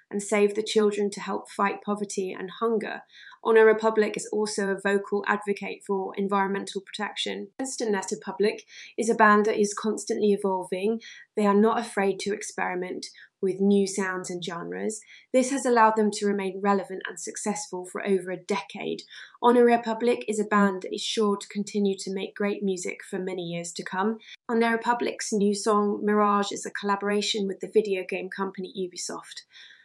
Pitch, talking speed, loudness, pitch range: 205 Hz, 175 wpm, -26 LUFS, 195-220 Hz